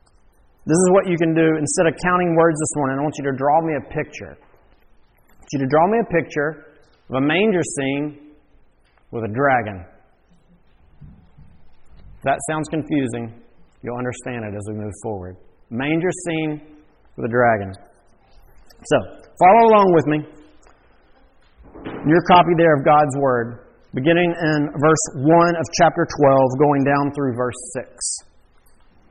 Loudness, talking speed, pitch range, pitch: -18 LUFS, 155 wpm, 120-160 Hz, 145 Hz